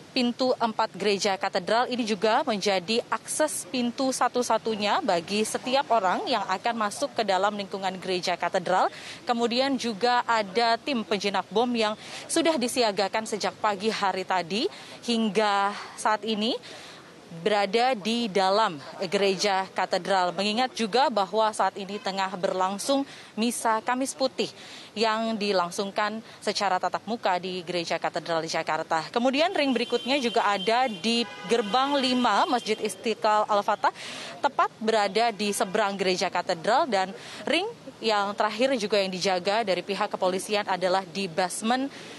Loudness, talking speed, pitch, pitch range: -26 LUFS, 130 wpm, 215 Hz, 195-235 Hz